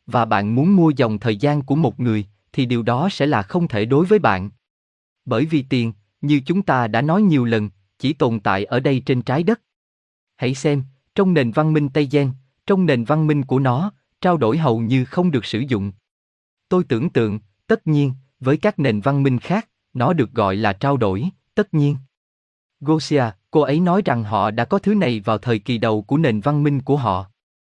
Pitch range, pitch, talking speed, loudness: 110-155 Hz, 135 Hz, 215 wpm, -19 LUFS